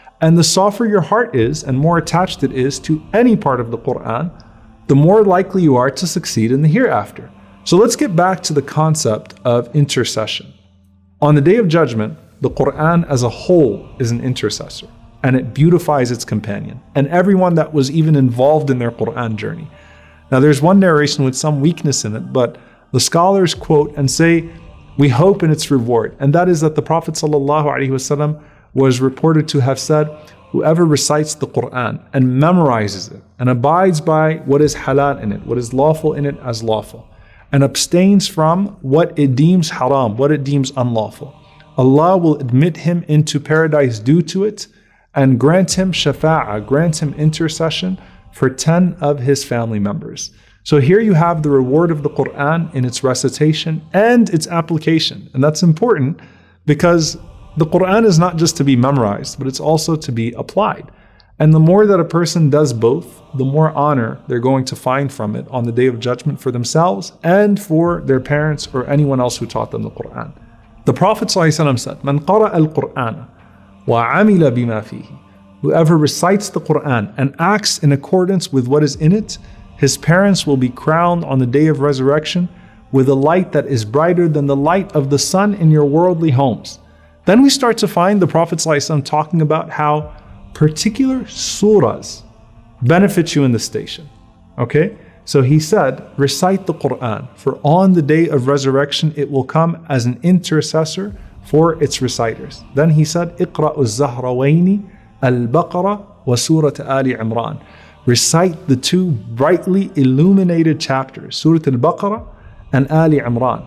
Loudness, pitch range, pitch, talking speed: -14 LUFS, 130-170 Hz, 150 Hz, 175 wpm